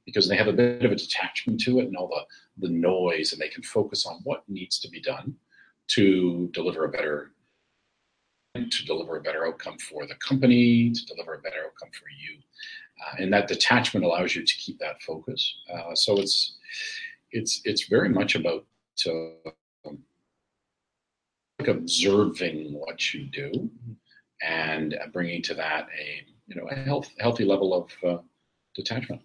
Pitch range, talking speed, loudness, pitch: 90-130 Hz, 170 wpm, -26 LUFS, 115 Hz